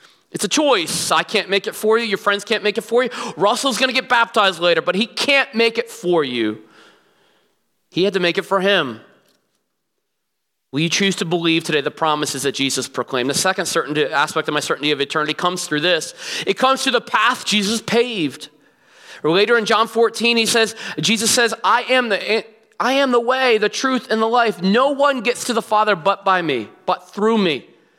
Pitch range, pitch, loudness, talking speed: 175-235 Hz, 210 Hz, -18 LUFS, 210 wpm